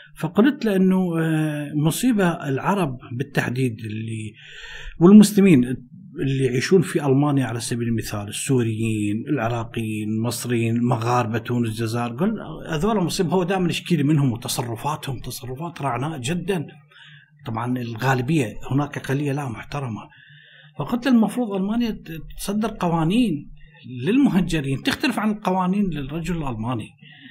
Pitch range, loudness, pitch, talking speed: 125-180 Hz, -22 LUFS, 145 Hz, 105 wpm